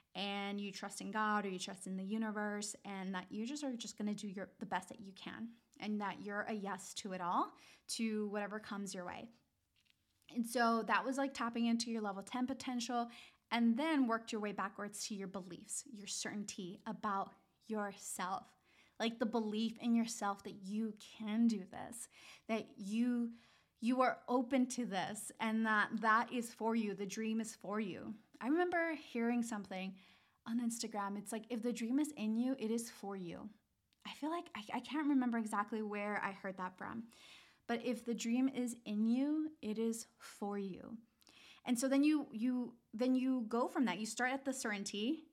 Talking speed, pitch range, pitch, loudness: 195 wpm, 205-245 Hz, 225 Hz, -40 LUFS